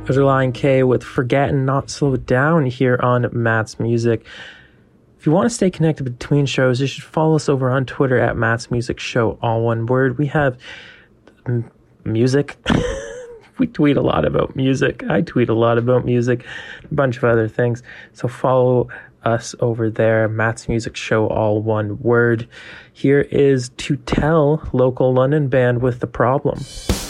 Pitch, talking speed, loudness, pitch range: 125 Hz, 165 wpm, -18 LUFS, 115-140 Hz